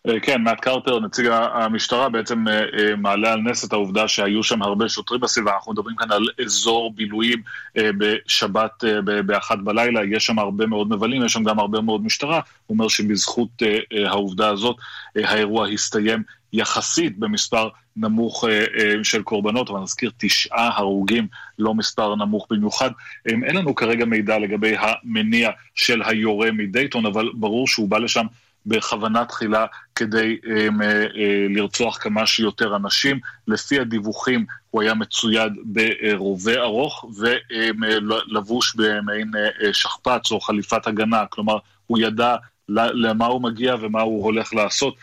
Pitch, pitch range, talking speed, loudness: 110 Hz, 105-115 Hz, 140 wpm, -20 LUFS